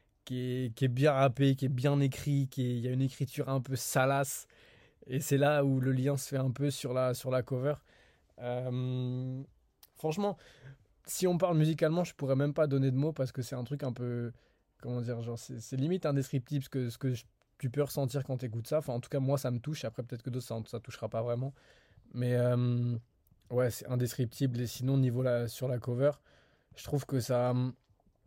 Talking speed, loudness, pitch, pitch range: 225 wpm, -33 LUFS, 130 Hz, 120-140 Hz